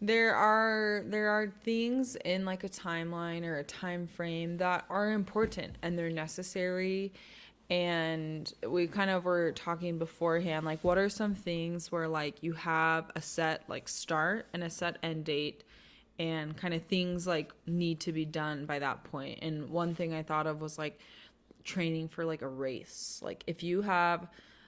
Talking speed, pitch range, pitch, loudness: 180 wpm, 160-185 Hz, 170 Hz, -34 LUFS